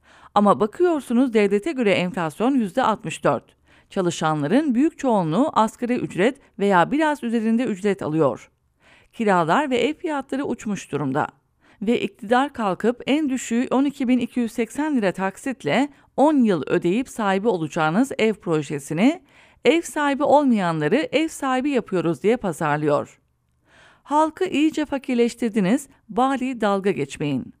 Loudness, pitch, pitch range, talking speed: -22 LUFS, 235 Hz, 195-270 Hz, 110 wpm